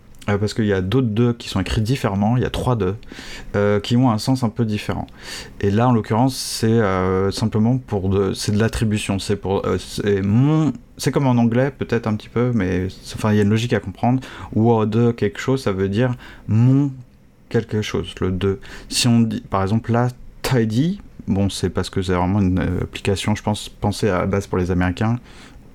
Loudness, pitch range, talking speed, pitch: -20 LUFS, 100-120 Hz, 220 wpm, 110 Hz